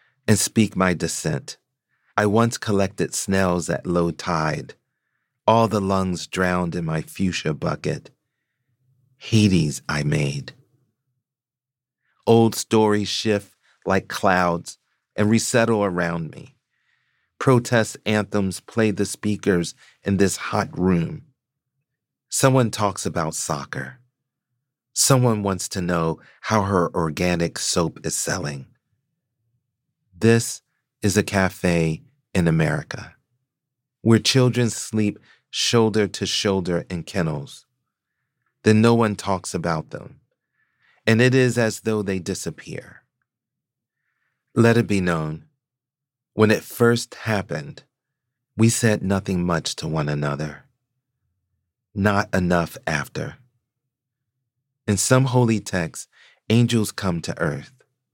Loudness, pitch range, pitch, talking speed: -21 LUFS, 90-125 Hz, 110 Hz, 110 wpm